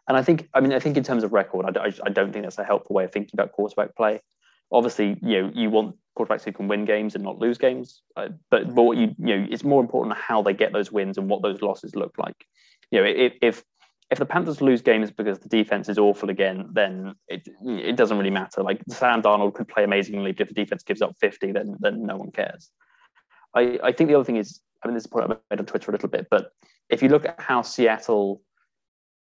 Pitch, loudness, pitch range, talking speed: 110 Hz, -23 LUFS, 100-125 Hz, 255 wpm